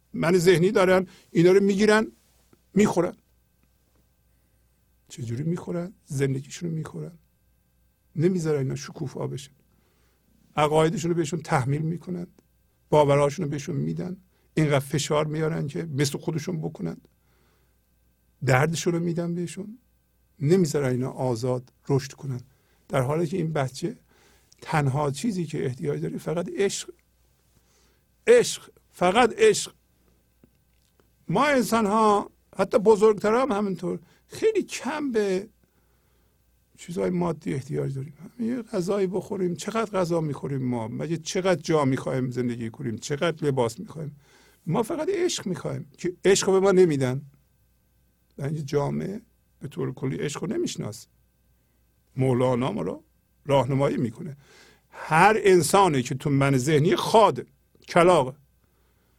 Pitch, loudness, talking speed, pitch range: 160 Hz, -24 LUFS, 120 wpm, 130-185 Hz